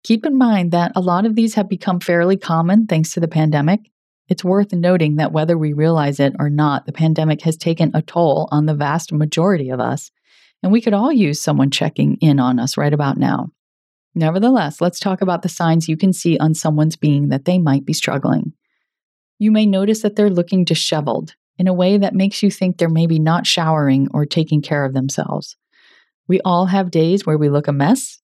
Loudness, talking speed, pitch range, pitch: -16 LUFS, 210 wpm, 150-190 Hz, 165 Hz